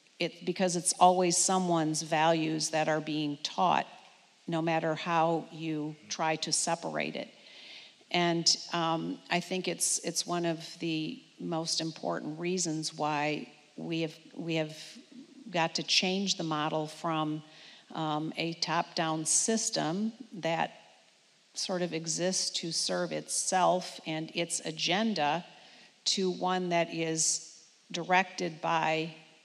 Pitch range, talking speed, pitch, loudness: 160-175 Hz, 125 wpm, 165 Hz, -30 LUFS